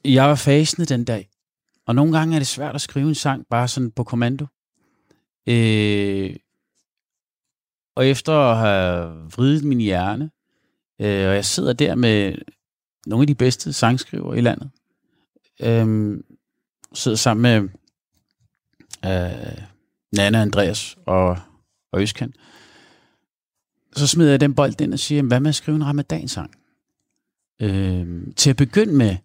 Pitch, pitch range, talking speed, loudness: 120 Hz, 100-140 Hz, 140 wpm, -19 LUFS